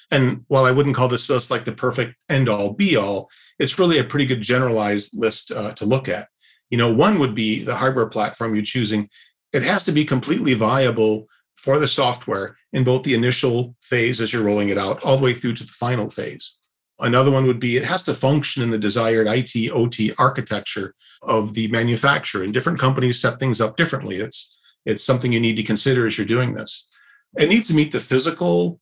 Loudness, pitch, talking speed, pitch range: -20 LUFS, 125 Hz, 215 wpm, 110-135 Hz